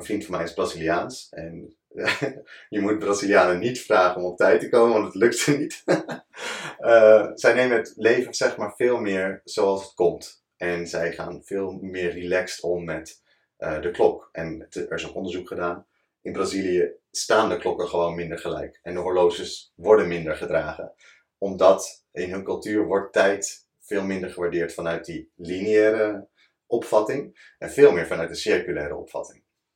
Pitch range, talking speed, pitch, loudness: 85-110 Hz, 175 wpm, 95 Hz, -23 LUFS